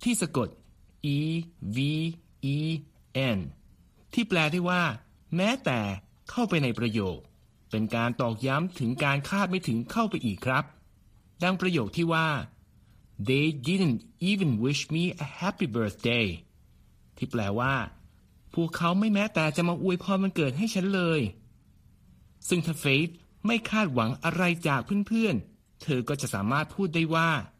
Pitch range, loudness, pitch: 120-180 Hz, -28 LUFS, 155 Hz